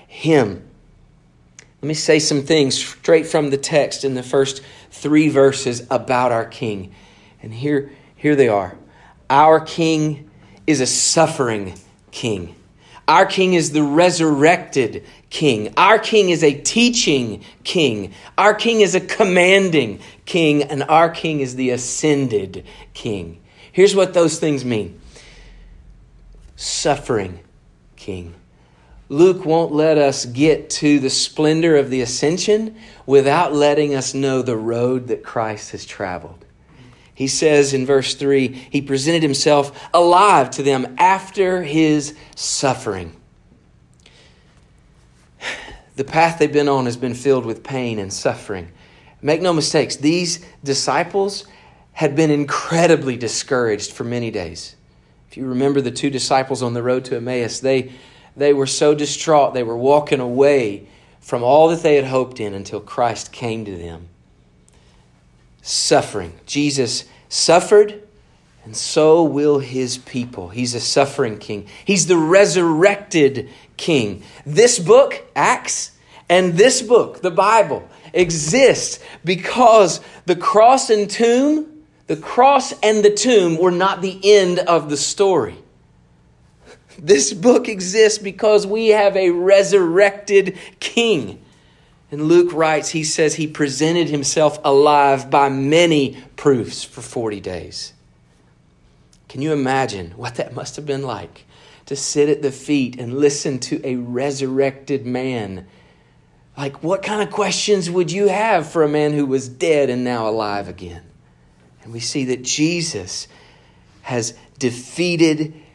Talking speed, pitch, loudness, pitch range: 135 wpm, 145 Hz, -17 LUFS, 125-170 Hz